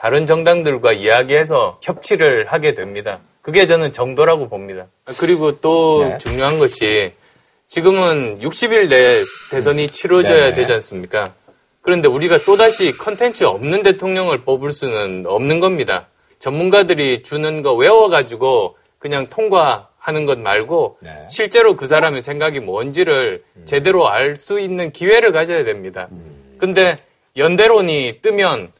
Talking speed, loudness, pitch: 300 characters per minute, -14 LUFS, 195 Hz